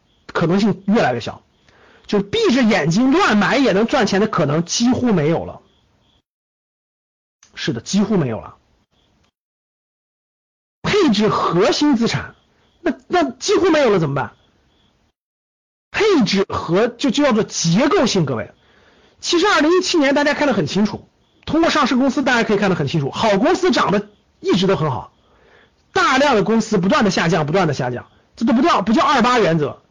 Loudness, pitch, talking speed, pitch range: -17 LUFS, 220 Hz, 250 characters per minute, 195-290 Hz